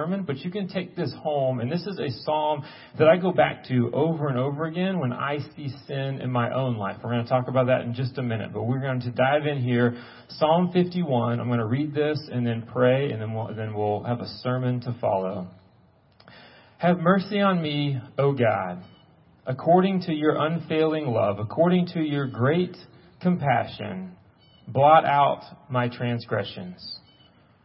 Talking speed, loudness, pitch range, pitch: 185 wpm, -25 LUFS, 120-155 Hz, 135 Hz